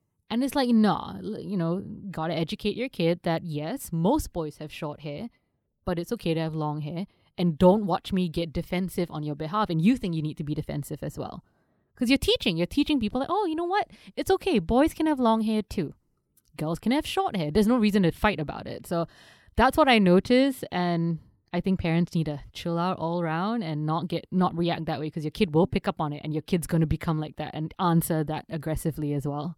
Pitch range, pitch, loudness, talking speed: 160-215 Hz, 175 Hz, -27 LUFS, 245 wpm